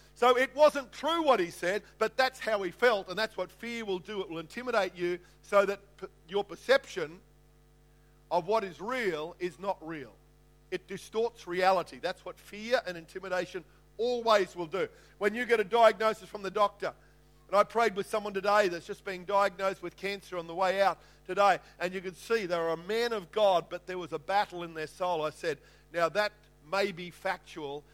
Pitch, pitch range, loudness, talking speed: 190 Hz, 170-215 Hz, -31 LUFS, 200 wpm